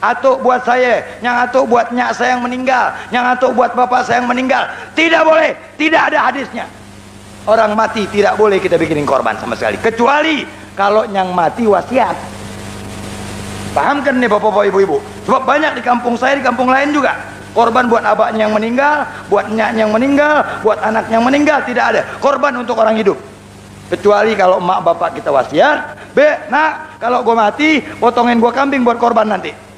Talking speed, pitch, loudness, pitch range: 175 wpm, 235 Hz, -13 LUFS, 200-260 Hz